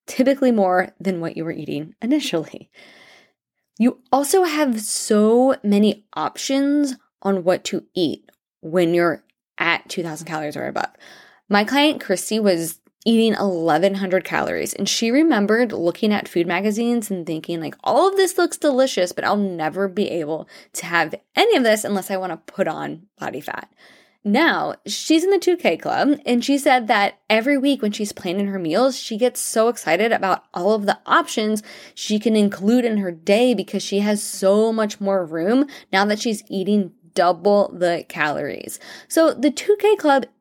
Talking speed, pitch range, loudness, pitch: 170 wpm, 190-250 Hz, -20 LUFS, 210 Hz